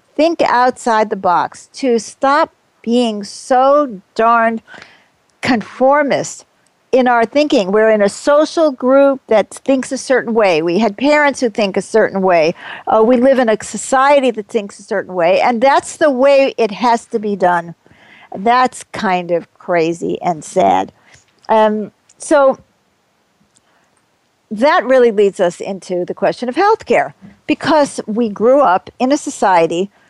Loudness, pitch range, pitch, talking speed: -14 LUFS, 205-270 Hz, 235 Hz, 150 wpm